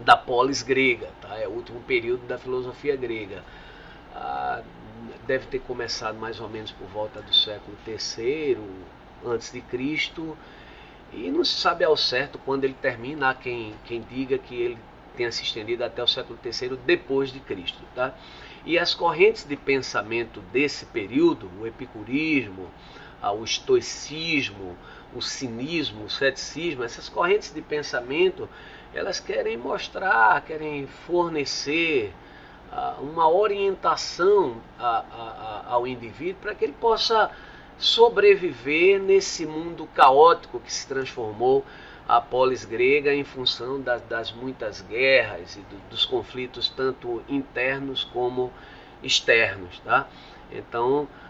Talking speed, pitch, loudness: 125 wpm, 155 Hz, -24 LUFS